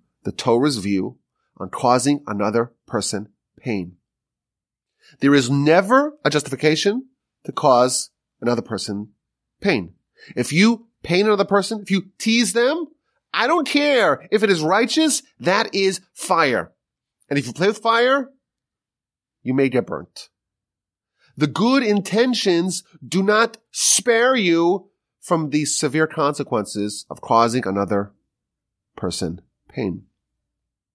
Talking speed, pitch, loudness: 120 wpm, 165 Hz, -19 LUFS